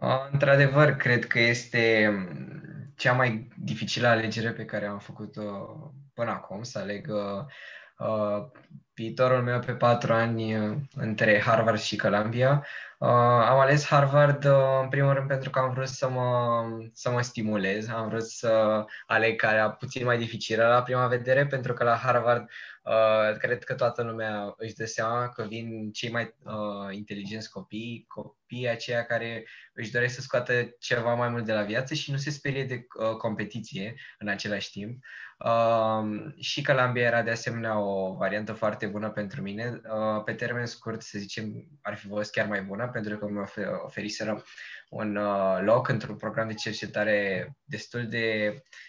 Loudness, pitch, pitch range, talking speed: -27 LUFS, 115 Hz, 110-125 Hz, 165 wpm